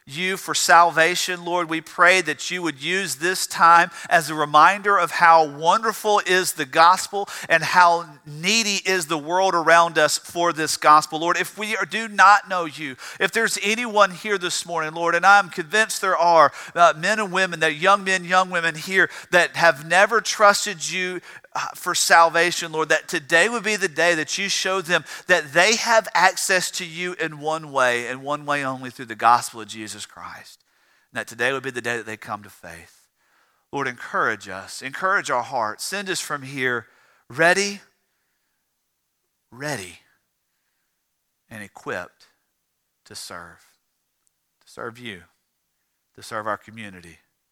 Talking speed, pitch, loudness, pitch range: 170 wpm, 170 Hz, -19 LUFS, 150-190 Hz